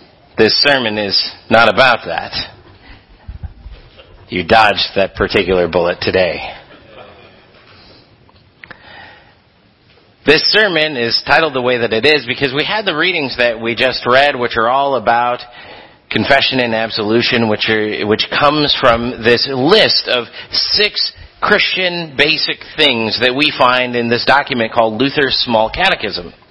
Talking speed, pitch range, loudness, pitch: 135 wpm, 115-145 Hz, -13 LUFS, 125 Hz